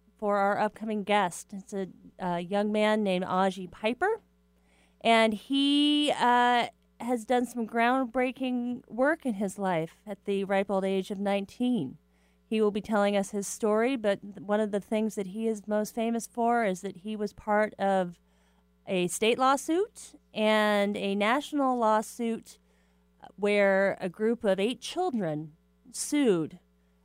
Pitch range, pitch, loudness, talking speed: 195-230 Hz, 210 Hz, -28 LUFS, 150 wpm